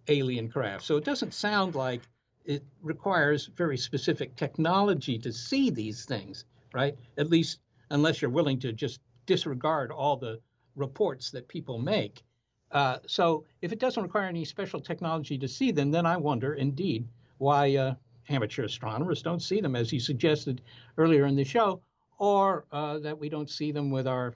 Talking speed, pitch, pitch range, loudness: 170 wpm, 145 Hz, 125-165 Hz, -29 LUFS